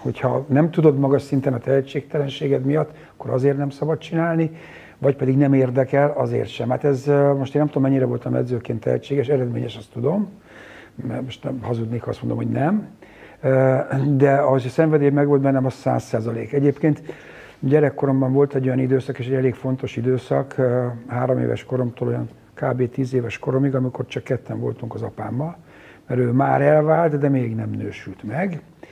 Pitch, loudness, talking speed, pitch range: 135 Hz, -21 LUFS, 175 wpm, 125-145 Hz